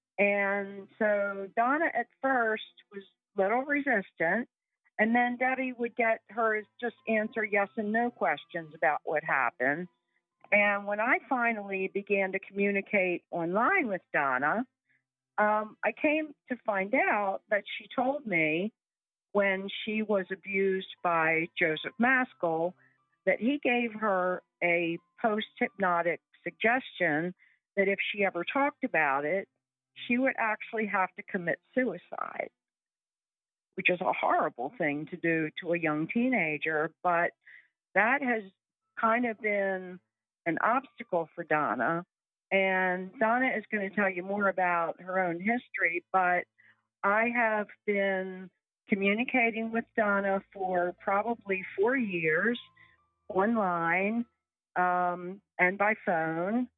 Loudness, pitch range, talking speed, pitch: -29 LUFS, 180-230 Hz, 130 wpm, 200 Hz